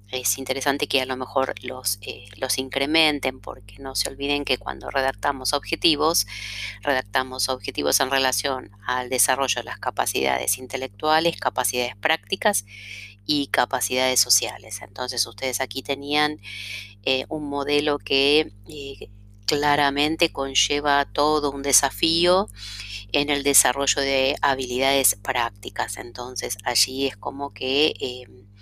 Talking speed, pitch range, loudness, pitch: 125 wpm, 120-145 Hz, -22 LUFS, 130 Hz